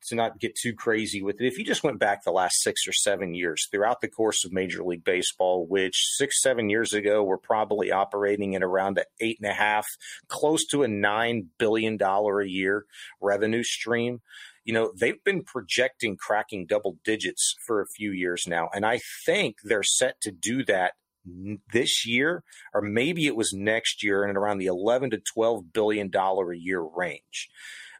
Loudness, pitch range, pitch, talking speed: -26 LUFS, 95-110 Hz, 105 Hz, 195 wpm